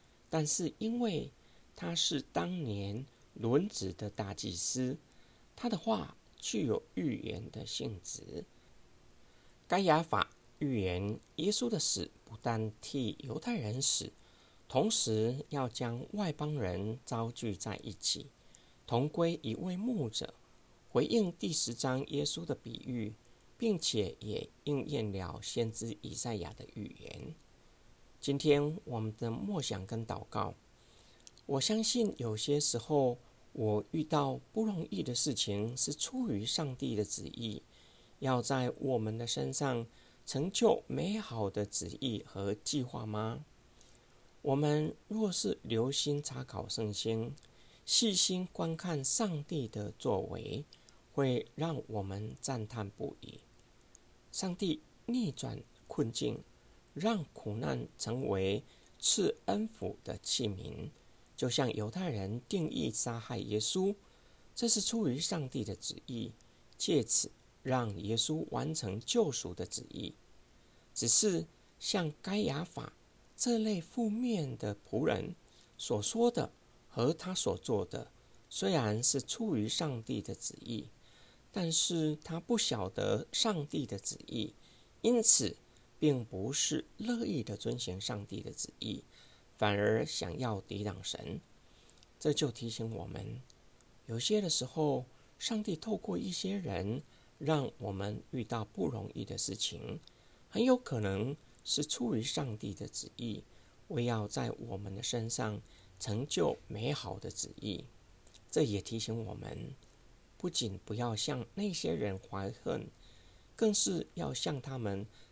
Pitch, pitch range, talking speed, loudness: 125 Hz, 110-160 Hz, 185 characters per minute, -35 LUFS